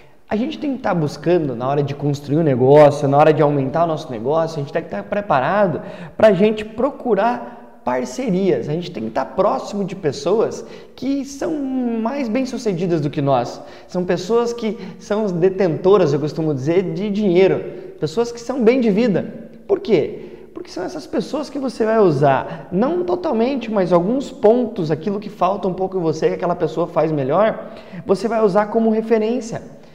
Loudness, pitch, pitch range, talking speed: -18 LUFS, 205 Hz, 165-235 Hz, 190 wpm